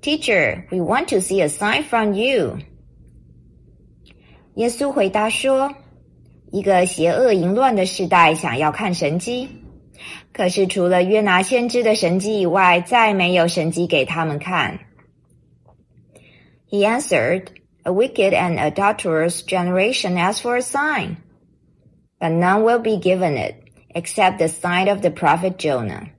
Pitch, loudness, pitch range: 185 Hz, -18 LUFS, 170-215 Hz